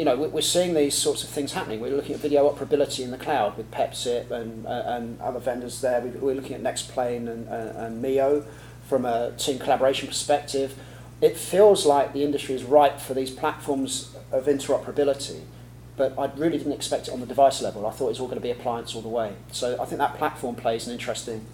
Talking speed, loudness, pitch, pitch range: 225 wpm, -25 LUFS, 135 Hz, 120-145 Hz